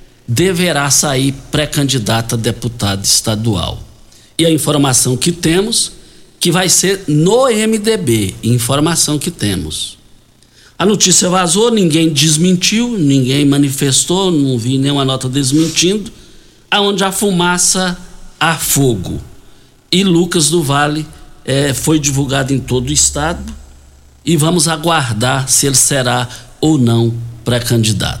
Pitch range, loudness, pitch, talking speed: 120-175 Hz, -12 LUFS, 140 Hz, 120 wpm